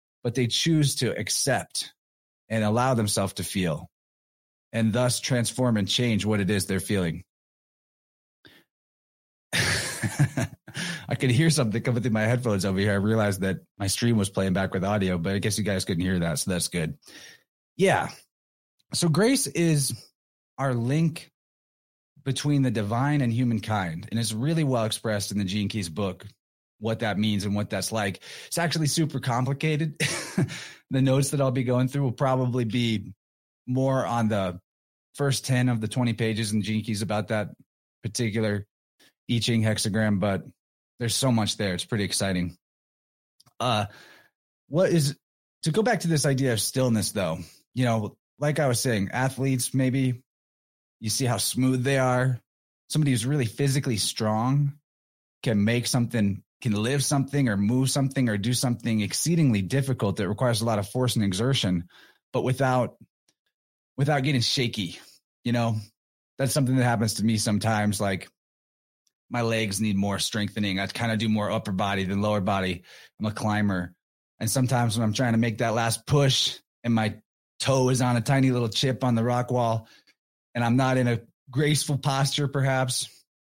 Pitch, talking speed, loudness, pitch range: 115 Hz, 170 wpm, -25 LUFS, 105-130 Hz